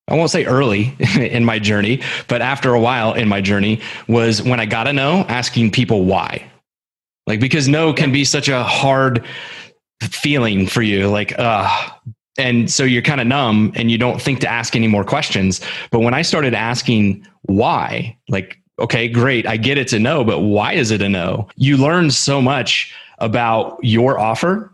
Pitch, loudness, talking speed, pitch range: 120 Hz, -16 LUFS, 190 wpm, 110-135 Hz